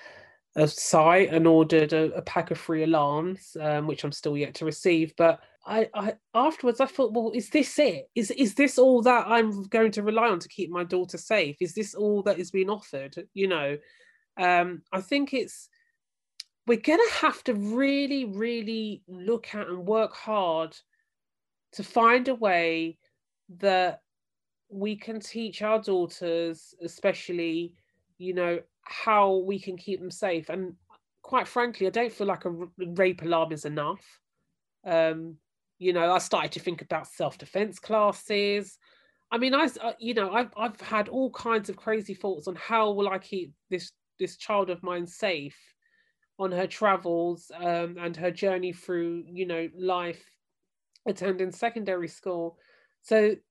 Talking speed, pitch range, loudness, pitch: 165 wpm, 170-225 Hz, -27 LUFS, 190 Hz